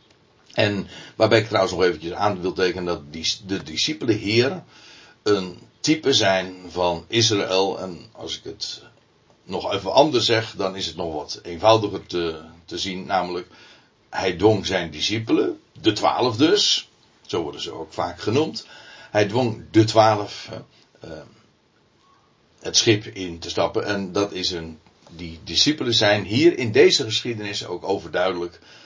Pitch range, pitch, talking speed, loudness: 90-110 Hz, 95 Hz, 150 wpm, -21 LUFS